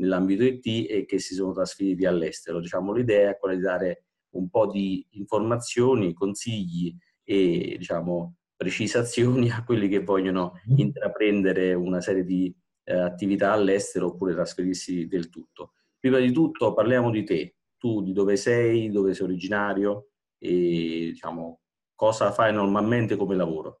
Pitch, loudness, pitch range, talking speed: 100 Hz, -25 LUFS, 90-115 Hz, 145 wpm